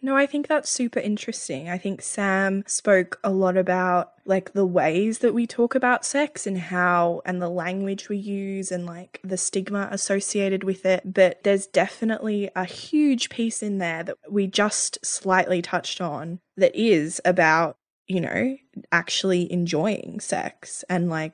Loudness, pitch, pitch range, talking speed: -23 LUFS, 195 Hz, 180-215 Hz, 165 wpm